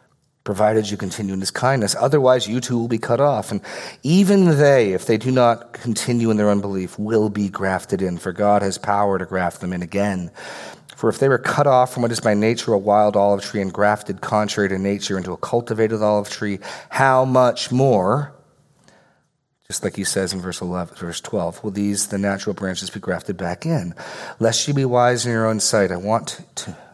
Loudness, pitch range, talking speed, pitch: -19 LUFS, 100-120 Hz, 210 wpm, 105 Hz